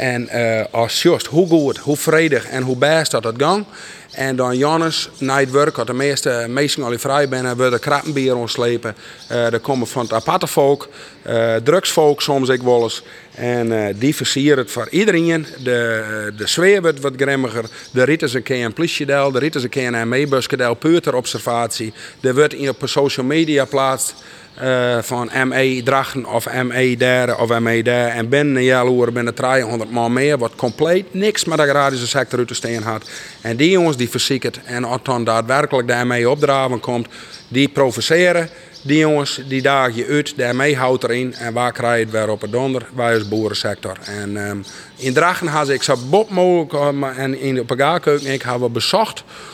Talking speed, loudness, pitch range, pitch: 190 wpm, -17 LUFS, 120-145 Hz, 130 Hz